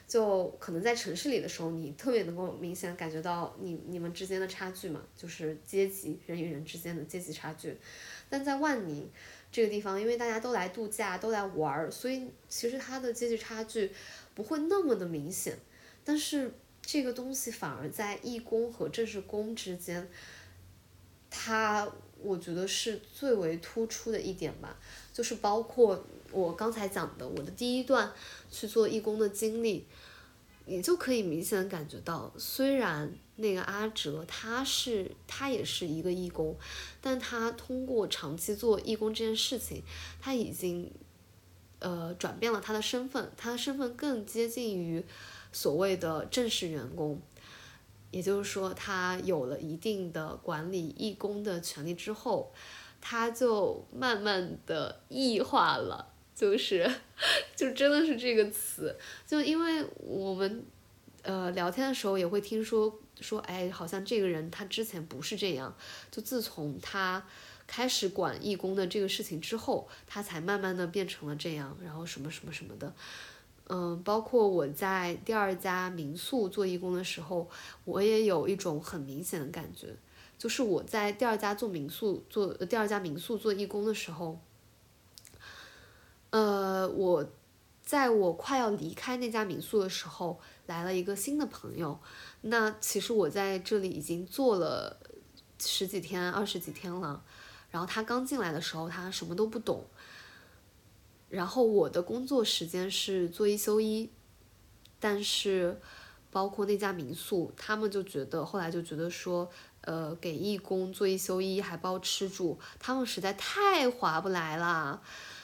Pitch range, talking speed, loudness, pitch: 170-225 Hz, 235 characters per minute, -33 LUFS, 195 Hz